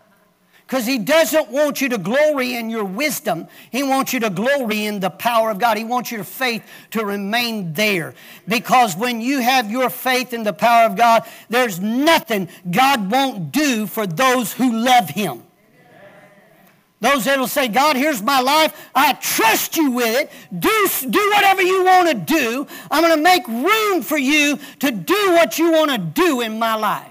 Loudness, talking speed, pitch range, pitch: -17 LUFS, 190 wpm, 225-300 Hz, 255 Hz